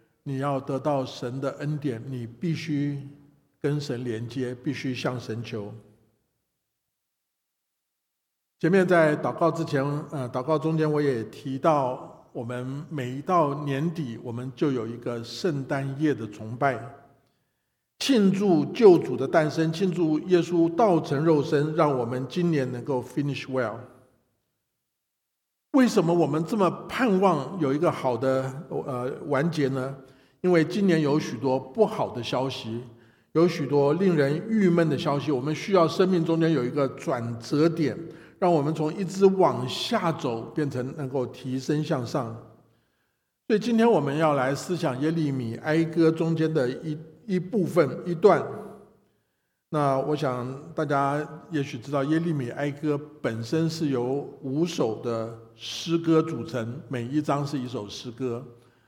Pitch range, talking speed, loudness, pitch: 130-160 Hz, 220 characters per minute, -26 LUFS, 145 Hz